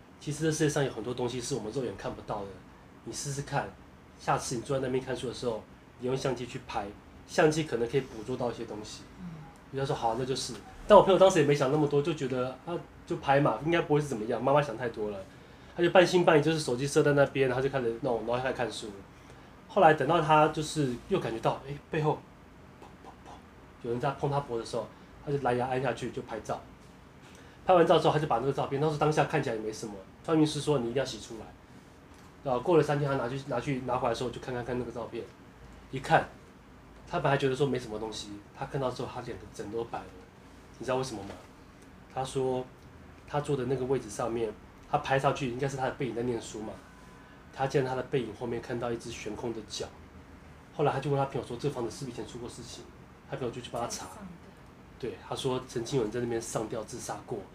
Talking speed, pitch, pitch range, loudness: 350 characters per minute, 130 Hz, 115-145 Hz, -30 LUFS